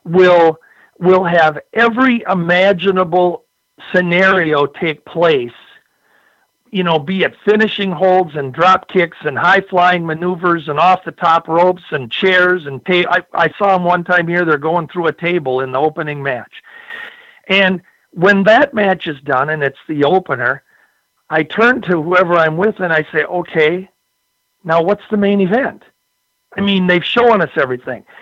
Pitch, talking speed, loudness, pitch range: 180 Hz, 165 wpm, -14 LUFS, 160-195 Hz